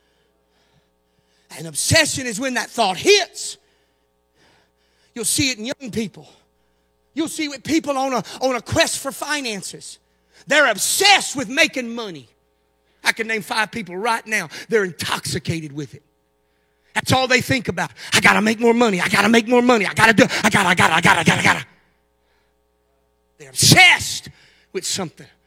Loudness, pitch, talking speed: -17 LUFS, 170 Hz, 170 wpm